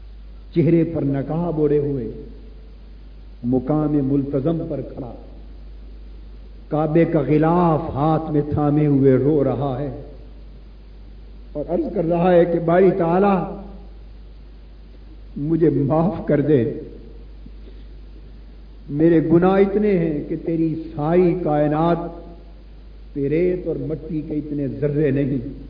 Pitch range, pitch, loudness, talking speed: 135-165 Hz, 150 Hz, -19 LUFS, 110 wpm